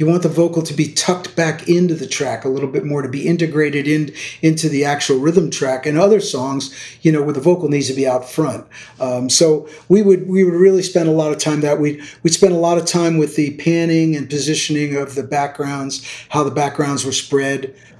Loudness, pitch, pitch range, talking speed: -16 LUFS, 150 Hz, 140-165 Hz, 235 wpm